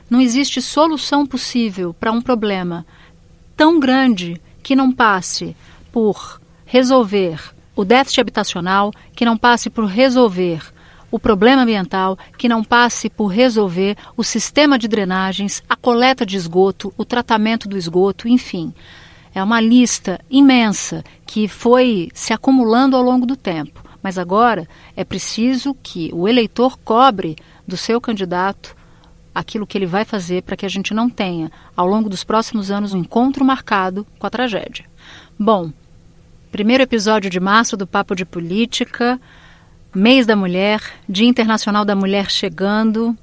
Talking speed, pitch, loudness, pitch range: 145 wpm, 220 Hz, -16 LUFS, 190-245 Hz